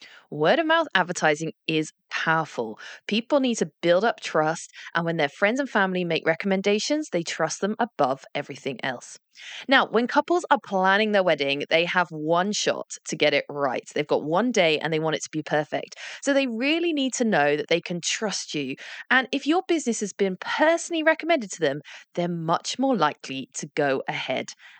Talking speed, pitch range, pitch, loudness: 195 wpm, 160-260 Hz, 190 Hz, -24 LUFS